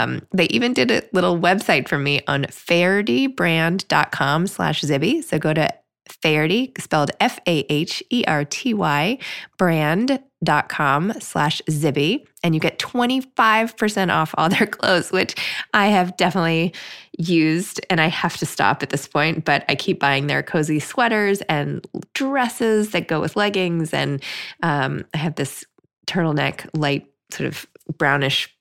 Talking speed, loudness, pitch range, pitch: 140 wpm, -20 LUFS, 150-200 Hz, 165 Hz